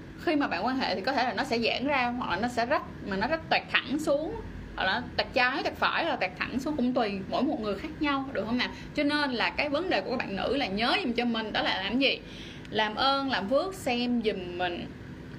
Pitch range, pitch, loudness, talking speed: 235-290 Hz, 255 Hz, -28 LUFS, 275 wpm